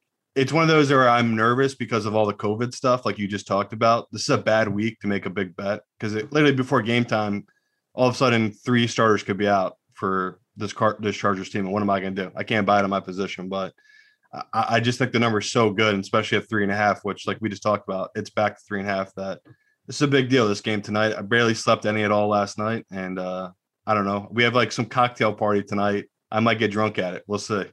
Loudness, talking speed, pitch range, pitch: -23 LUFS, 275 wpm, 100-120 Hz, 110 Hz